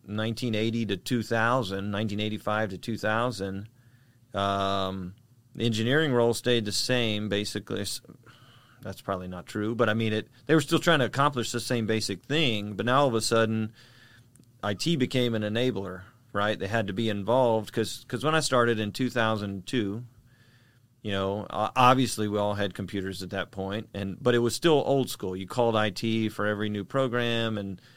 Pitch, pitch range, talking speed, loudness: 115 Hz, 105-125 Hz, 175 wpm, -27 LUFS